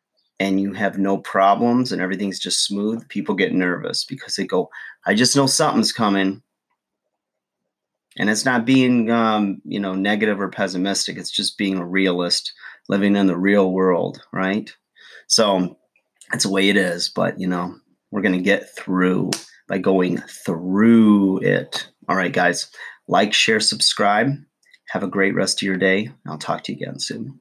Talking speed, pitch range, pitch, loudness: 170 wpm, 95-105 Hz, 100 Hz, -19 LUFS